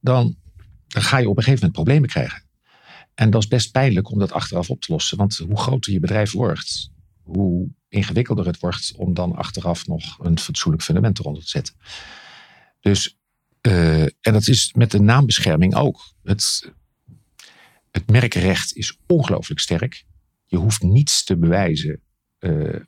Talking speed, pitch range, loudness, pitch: 165 wpm, 90-120 Hz, -19 LUFS, 100 Hz